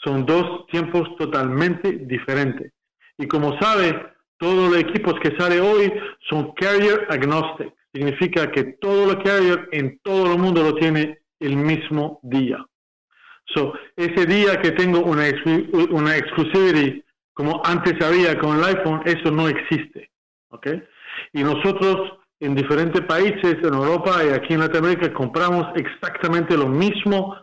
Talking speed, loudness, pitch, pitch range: 140 wpm, -20 LUFS, 165 Hz, 150-180 Hz